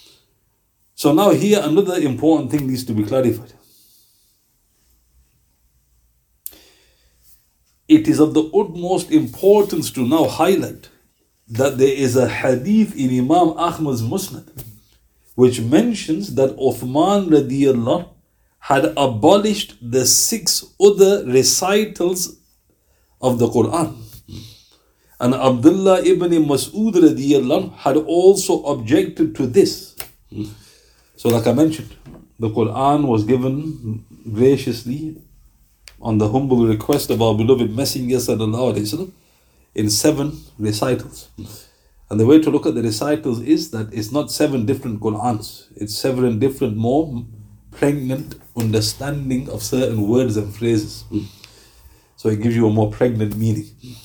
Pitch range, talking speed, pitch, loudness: 110-150 Hz, 115 wpm, 125 Hz, -17 LUFS